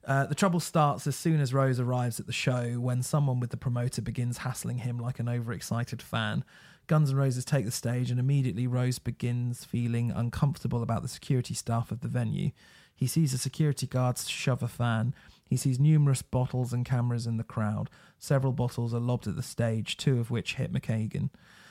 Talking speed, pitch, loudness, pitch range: 200 wpm, 125 Hz, -30 LUFS, 120-135 Hz